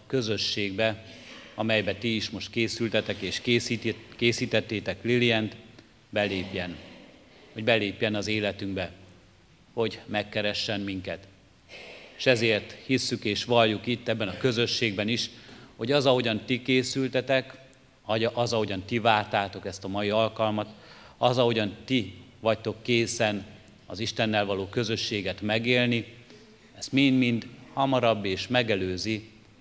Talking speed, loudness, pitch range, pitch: 115 wpm, -27 LUFS, 100-120 Hz, 110 Hz